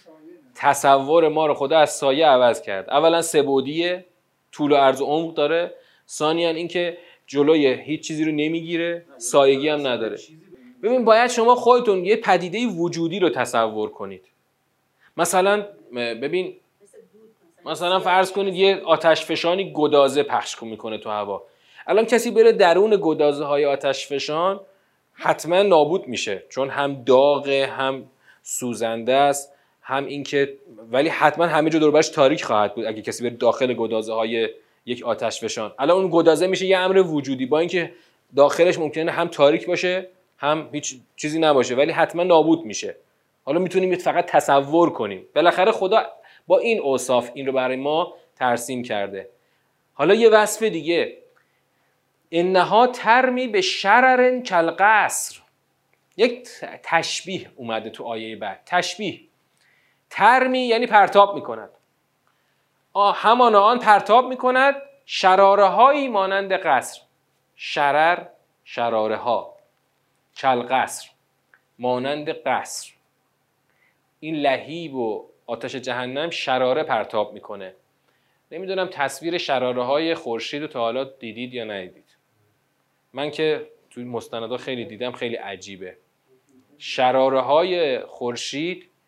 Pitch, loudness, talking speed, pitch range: 160 Hz, -20 LUFS, 130 wpm, 135-190 Hz